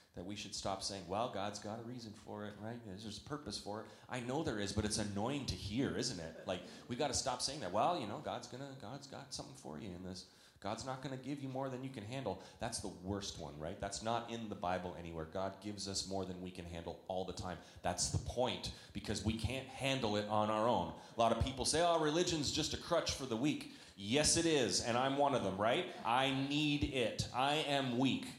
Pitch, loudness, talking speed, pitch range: 105 Hz, -39 LUFS, 250 wpm, 95-130 Hz